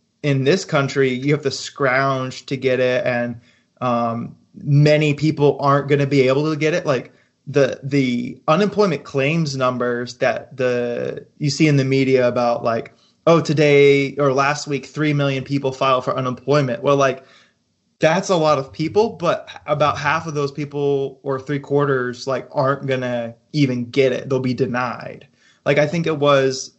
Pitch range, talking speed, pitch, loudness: 130-145 Hz, 175 wpm, 140 Hz, -19 LUFS